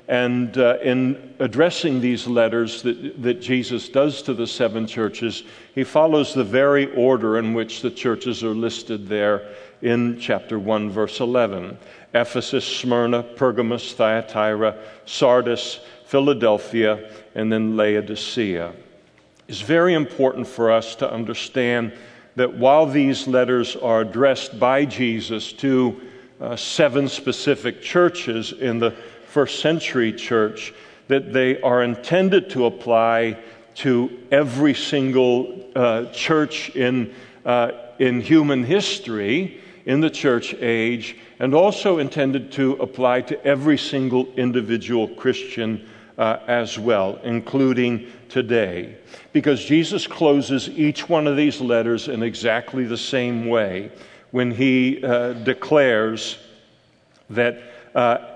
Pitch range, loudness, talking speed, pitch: 115-135 Hz, -20 LUFS, 120 wpm, 125 Hz